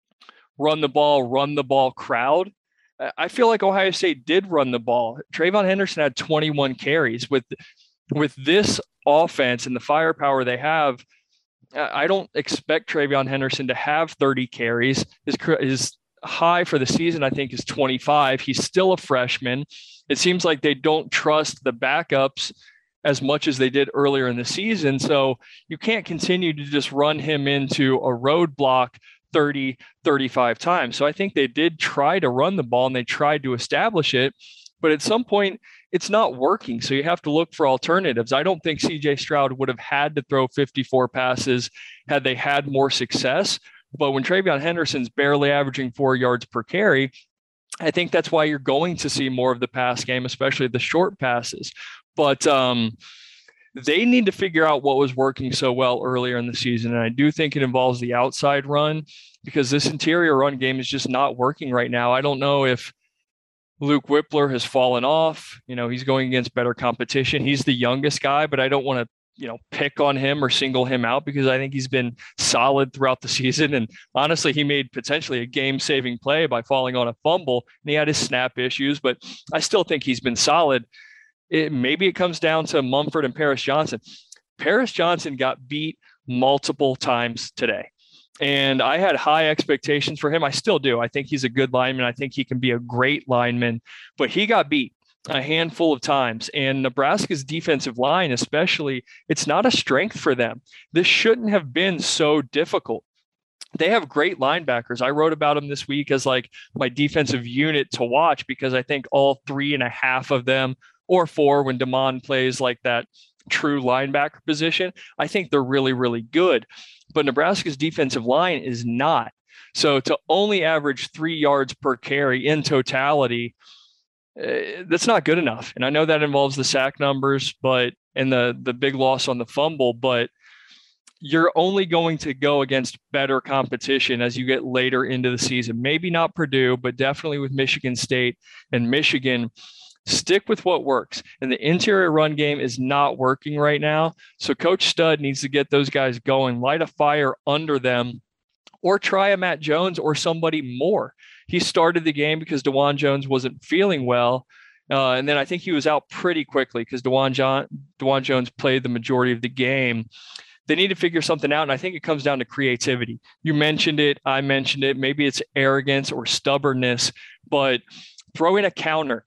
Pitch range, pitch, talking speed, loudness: 130-155 Hz, 140 Hz, 190 wpm, -21 LUFS